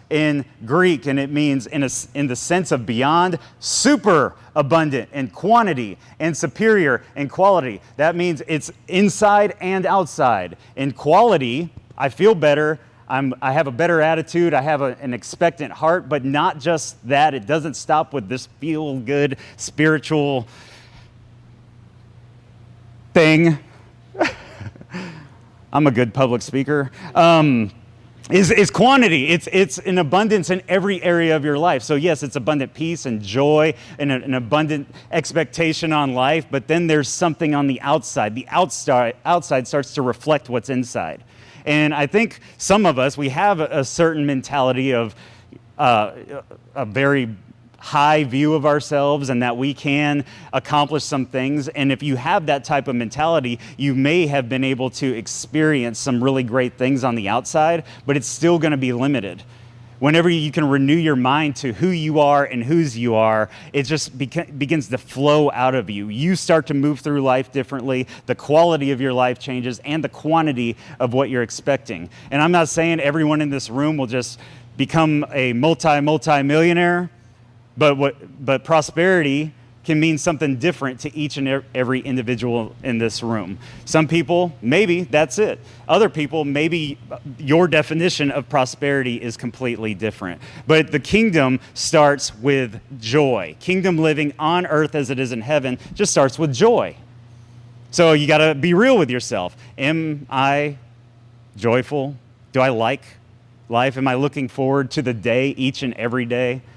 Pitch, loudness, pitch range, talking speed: 140 Hz, -19 LUFS, 125-155 Hz, 165 wpm